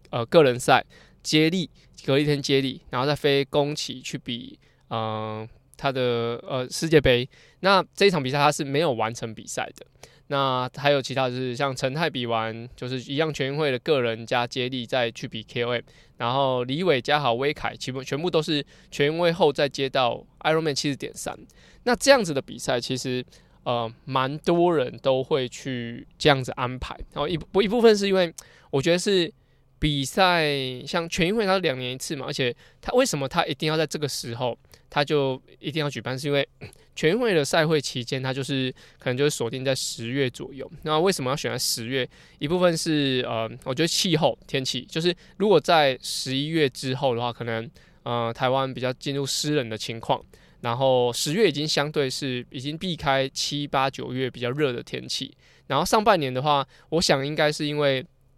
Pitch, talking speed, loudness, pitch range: 135 Hz, 290 characters per minute, -24 LUFS, 125-155 Hz